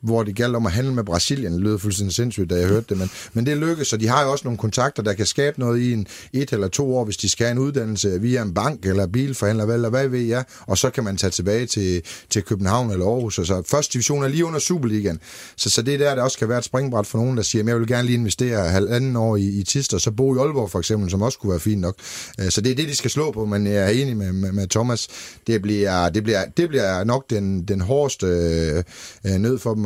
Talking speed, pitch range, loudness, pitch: 285 wpm, 100-125 Hz, -21 LUFS, 110 Hz